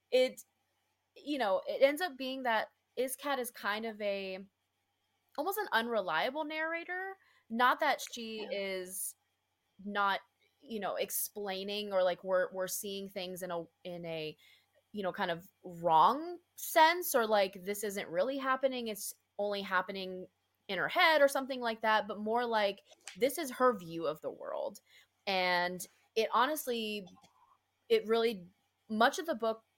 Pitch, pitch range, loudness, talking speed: 215 Hz, 190-270 Hz, -33 LUFS, 155 wpm